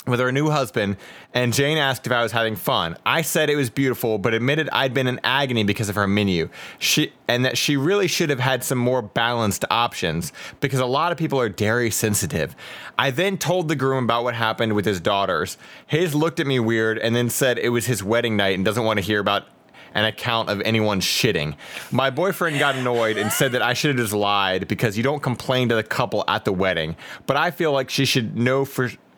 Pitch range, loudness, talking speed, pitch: 110-135 Hz, -21 LUFS, 230 wpm, 120 Hz